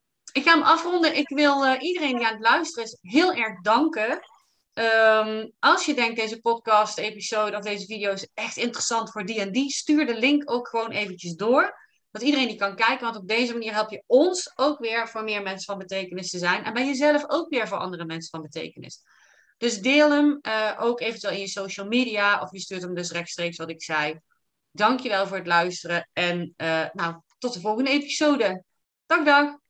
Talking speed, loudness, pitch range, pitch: 205 wpm, -24 LUFS, 195-270 Hz, 225 Hz